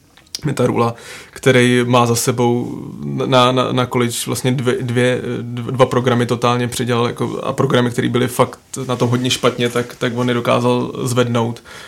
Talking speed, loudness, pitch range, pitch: 155 wpm, -17 LUFS, 120-125 Hz, 125 Hz